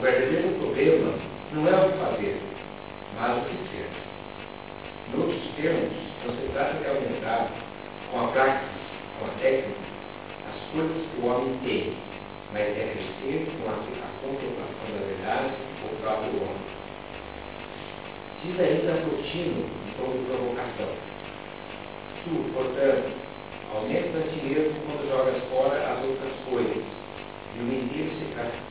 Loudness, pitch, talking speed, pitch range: -29 LUFS, 135 Hz, 135 wpm, 125-160 Hz